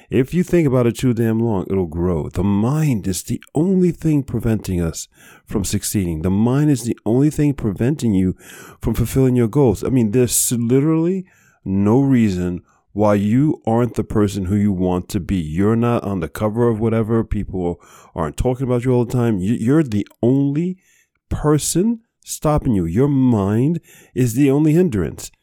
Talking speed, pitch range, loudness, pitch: 175 wpm, 100-140 Hz, -18 LUFS, 115 Hz